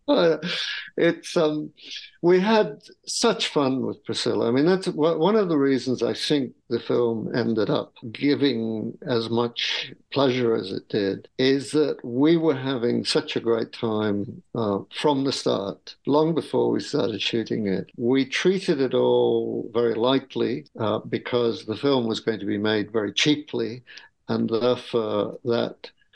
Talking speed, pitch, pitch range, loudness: 155 wpm, 125 Hz, 115-150 Hz, -24 LUFS